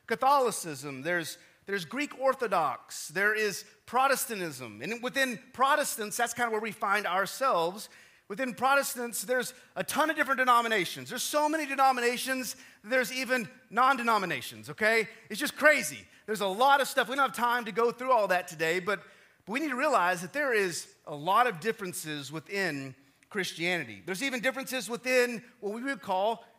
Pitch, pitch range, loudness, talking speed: 230 Hz, 185-260 Hz, -29 LUFS, 170 wpm